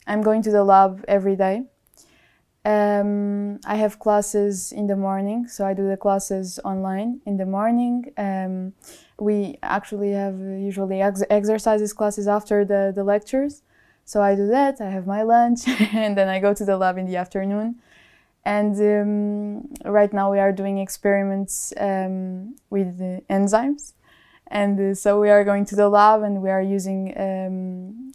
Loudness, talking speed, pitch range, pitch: -21 LUFS, 170 wpm, 195-210 Hz, 205 Hz